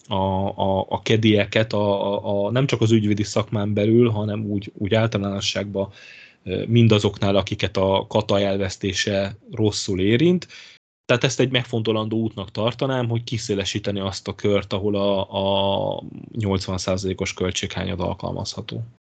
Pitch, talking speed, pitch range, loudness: 105 Hz, 130 wpm, 100-110 Hz, -22 LUFS